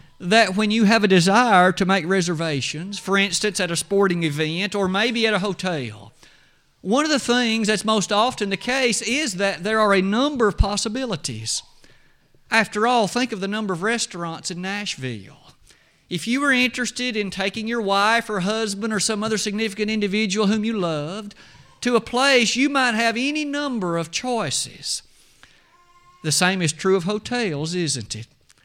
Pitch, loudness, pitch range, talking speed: 210 Hz, -21 LUFS, 180-230 Hz, 175 wpm